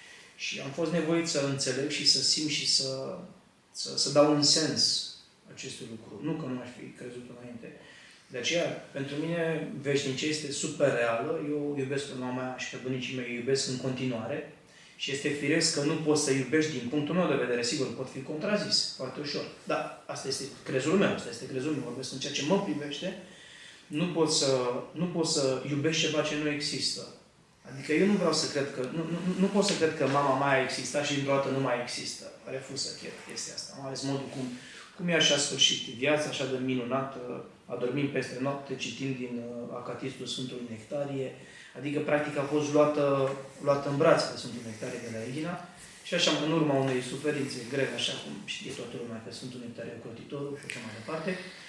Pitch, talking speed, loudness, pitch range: 140 Hz, 200 wpm, -30 LUFS, 130-155 Hz